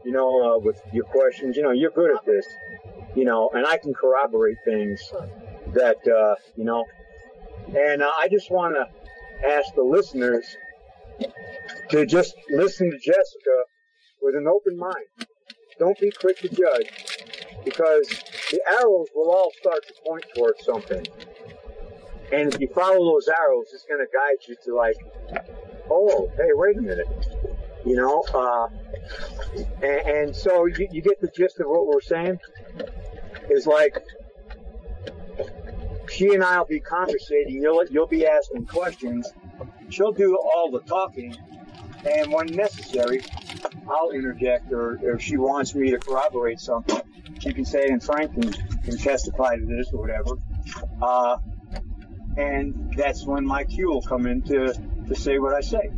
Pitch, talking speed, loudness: 160 Hz, 160 wpm, -23 LUFS